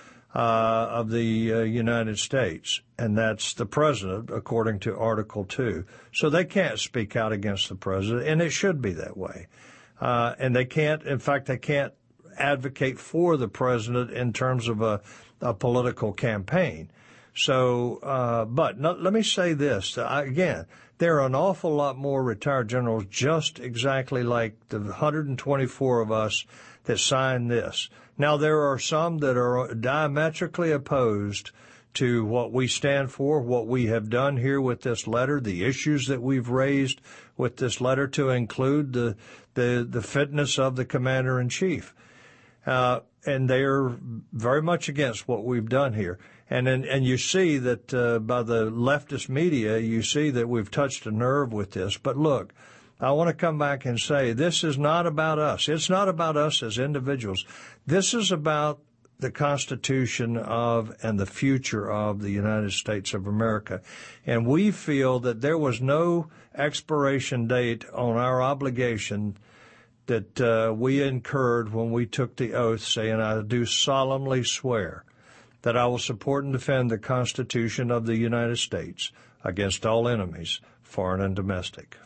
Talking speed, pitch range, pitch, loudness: 165 wpm, 115-140 Hz, 125 Hz, -26 LUFS